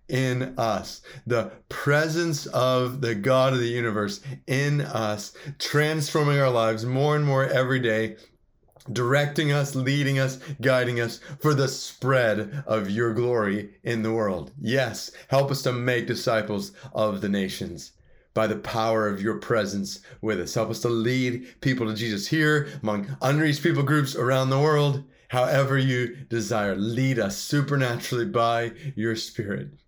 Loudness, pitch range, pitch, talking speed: -25 LUFS, 110-140 Hz, 125 Hz, 155 wpm